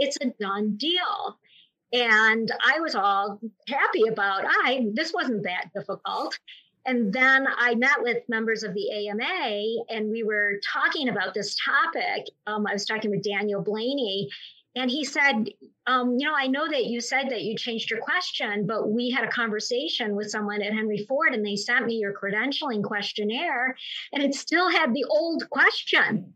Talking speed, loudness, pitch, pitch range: 180 wpm, -25 LUFS, 225 Hz, 210-270 Hz